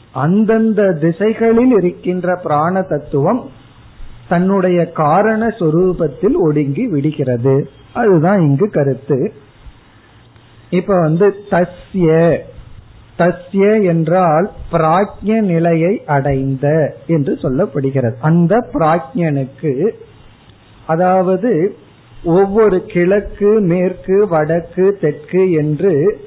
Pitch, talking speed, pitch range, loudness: 170 Hz, 75 wpm, 145-195 Hz, -14 LUFS